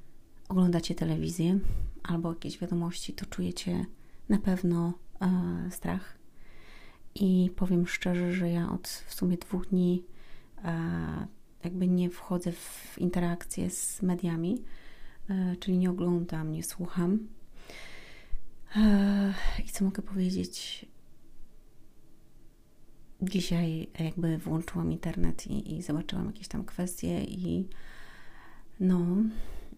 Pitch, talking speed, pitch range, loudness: 180 Hz, 105 wpm, 170-190 Hz, -31 LUFS